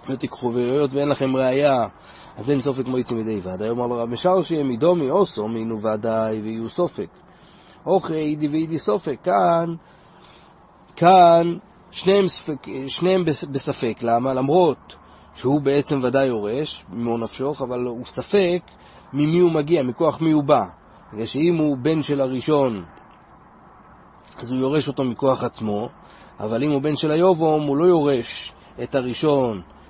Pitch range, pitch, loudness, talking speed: 120-160 Hz, 140 Hz, -21 LUFS, 145 wpm